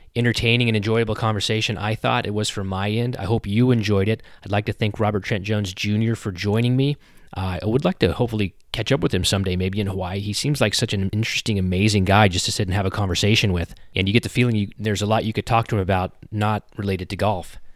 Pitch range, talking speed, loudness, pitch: 100-115 Hz, 255 wpm, -21 LUFS, 105 Hz